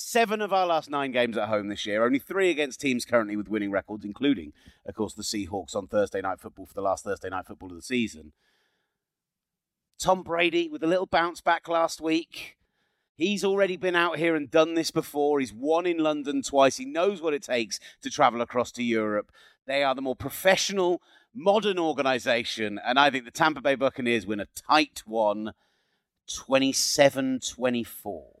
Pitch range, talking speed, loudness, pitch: 110-165 Hz, 190 wpm, -26 LUFS, 135 Hz